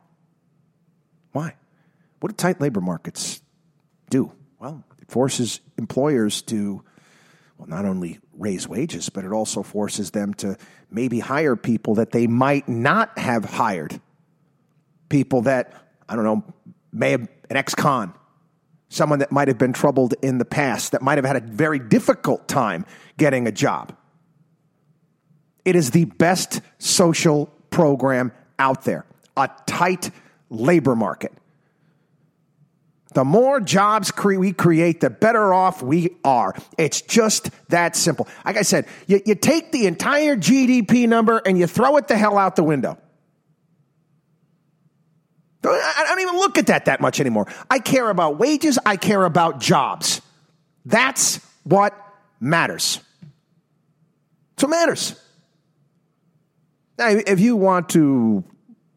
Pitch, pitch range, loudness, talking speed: 160 Hz, 145-185 Hz, -19 LUFS, 140 wpm